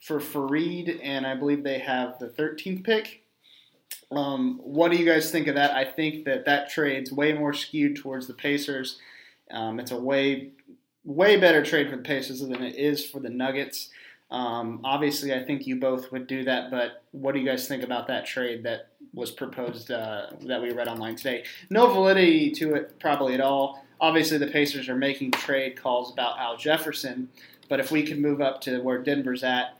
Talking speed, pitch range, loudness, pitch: 200 wpm, 130-155 Hz, -26 LUFS, 140 Hz